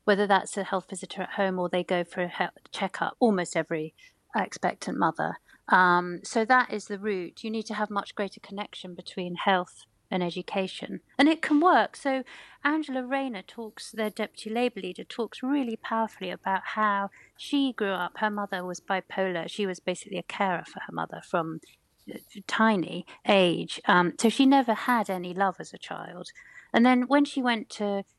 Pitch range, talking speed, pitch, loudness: 185-240 Hz, 185 wpm, 205 Hz, -27 LUFS